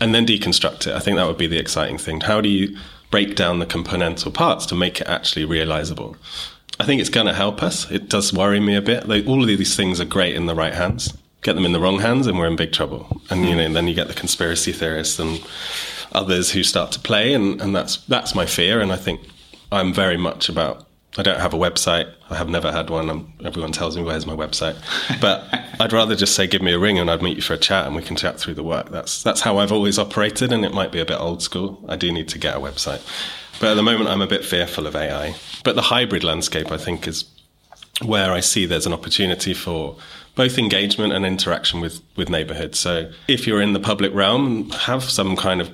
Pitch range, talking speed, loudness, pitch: 80-100 Hz, 250 wpm, -19 LUFS, 90 Hz